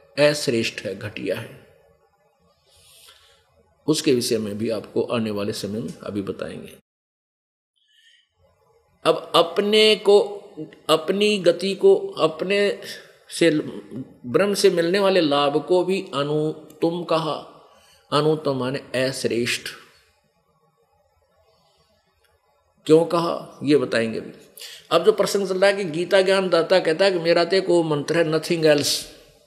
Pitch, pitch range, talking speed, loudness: 165 Hz, 145-195 Hz, 120 wpm, -21 LUFS